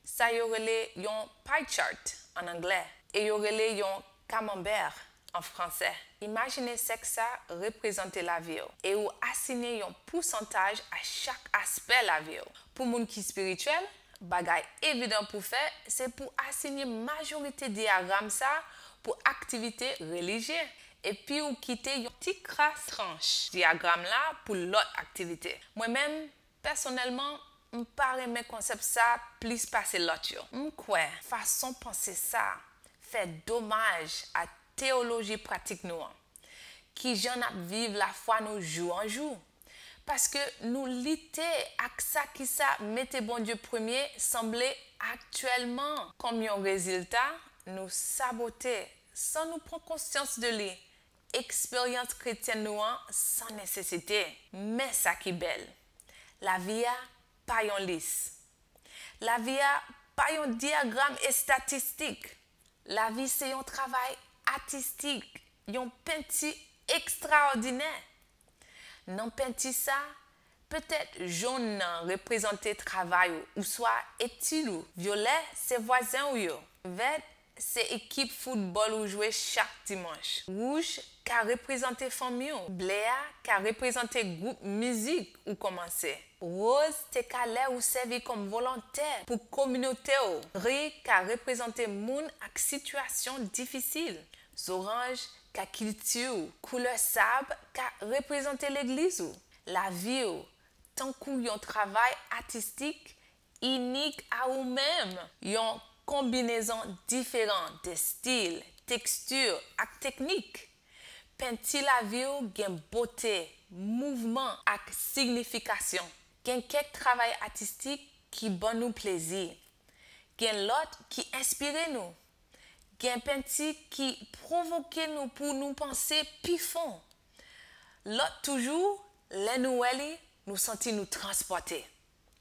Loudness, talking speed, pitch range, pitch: -32 LUFS, 125 wpm, 215-275 Hz, 245 Hz